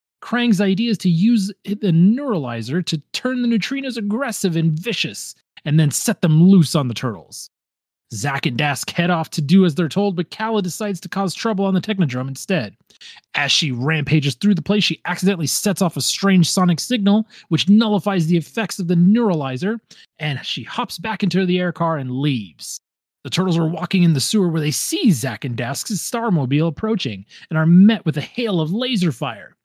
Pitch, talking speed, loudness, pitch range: 180 Hz, 195 wpm, -18 LUFS, 155-205 Hz